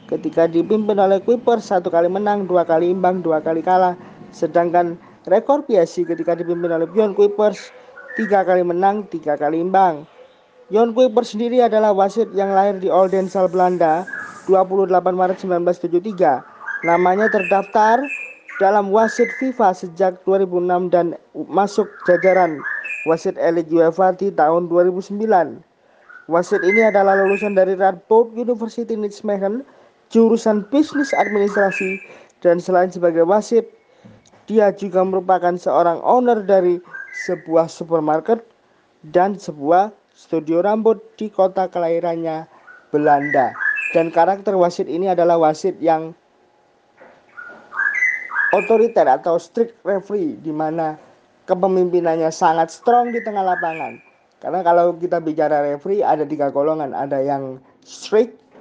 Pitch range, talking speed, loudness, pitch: 170-215 Hz, 120 wpm, -17 LUFS, 185 Hz